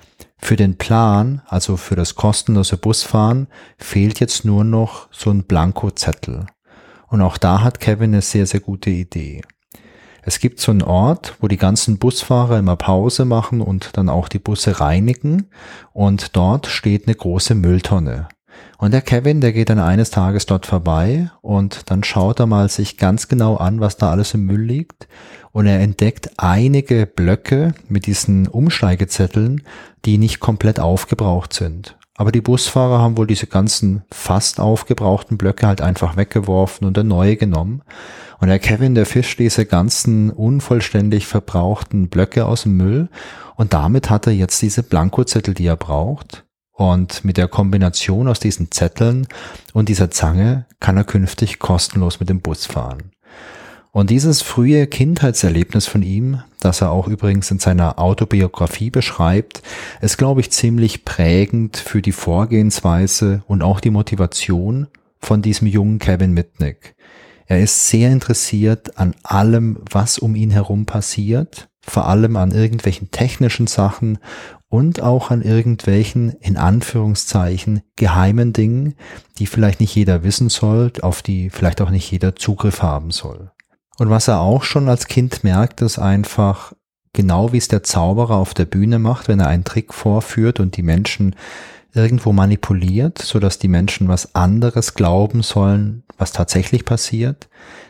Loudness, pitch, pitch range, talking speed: -16 LUFS, 105 Hz, 95-115 Hz, 155 wpm